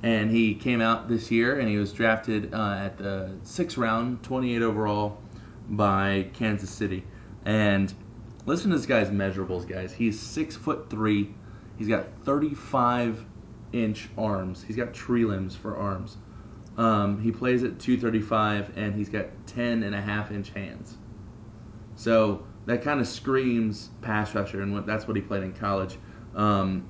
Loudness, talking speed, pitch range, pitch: -27 LUFS, 160 wpm, 100-115 Hz, 110 Hz